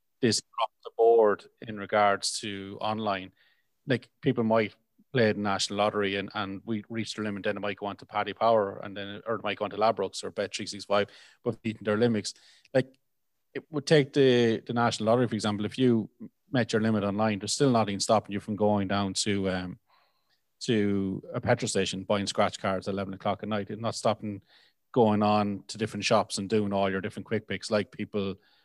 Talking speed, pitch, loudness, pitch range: 210 wpm, 105 Hz, -28 LUFS, 100-115 Hz